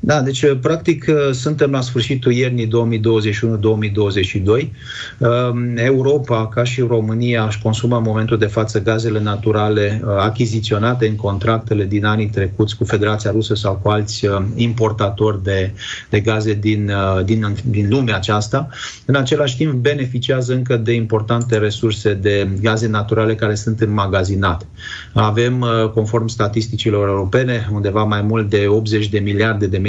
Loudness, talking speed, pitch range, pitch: -17 LUFS, 135 wpm, 105-120 Hz, 110 Hz